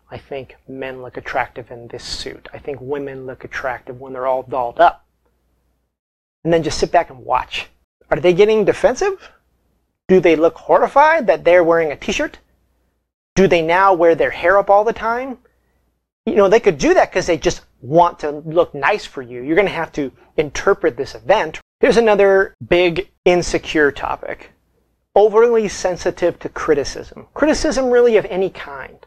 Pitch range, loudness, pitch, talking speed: 135-200 Hz, -16 LUFS, 175 Hz, 175 wpm